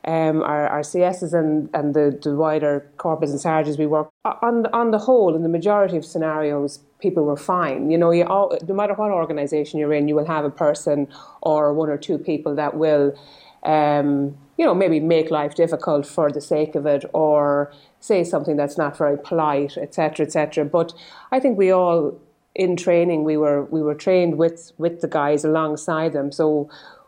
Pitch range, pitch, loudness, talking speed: 145-170 Hz, 155 Hz, -20 LUFS, 195 wpm